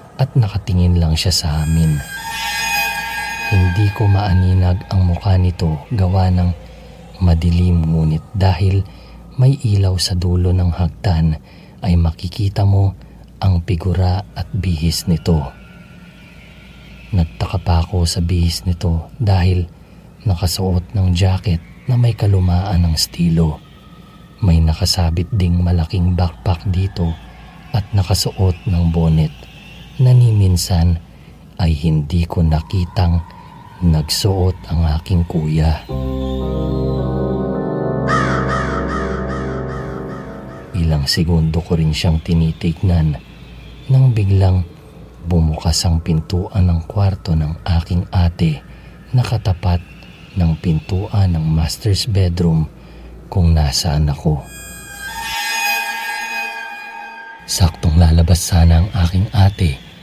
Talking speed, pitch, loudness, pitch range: 95 wpm, 90 Hz, -17 LUFS, 80-95 Hz